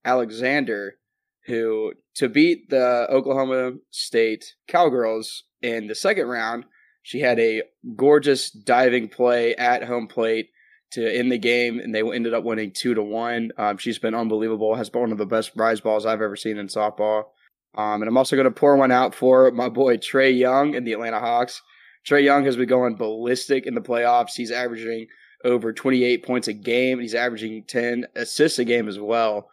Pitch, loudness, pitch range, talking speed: 120 Hz, -21 LUFS, 110-130 Hz, 190 wpm